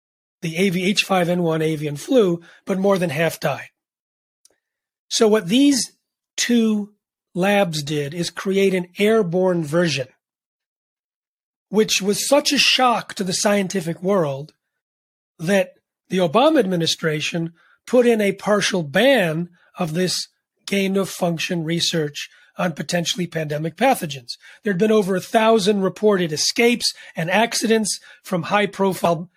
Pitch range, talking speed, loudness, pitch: 170-210 Hz, 120 wpm, -19 LUFS, 185 Hz